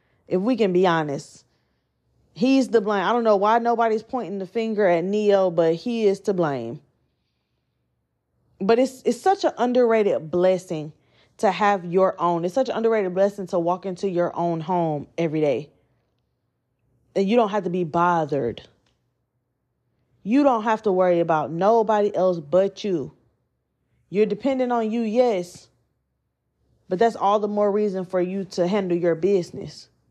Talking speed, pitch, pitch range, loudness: 160 wpm, 185 Hz, 160-215 Hz, -22 LUFS